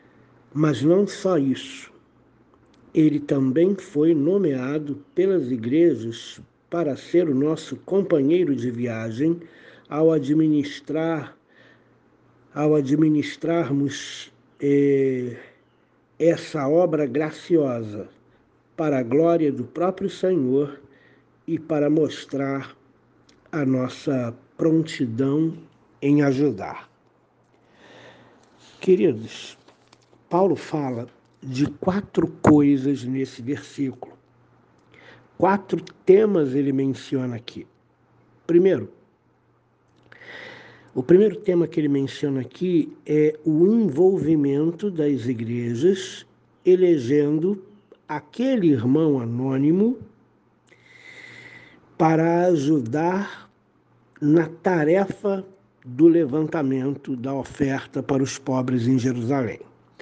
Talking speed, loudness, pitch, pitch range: 80 wpm, -22 LUFS, 150 Hz, 135-170 Hz